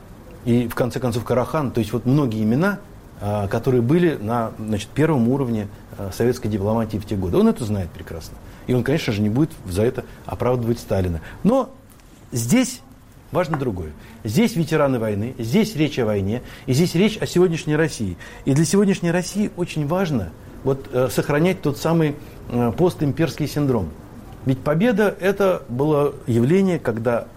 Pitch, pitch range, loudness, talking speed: 125 Hz, 110-160 Hz, -21 LUFS, 155 wpm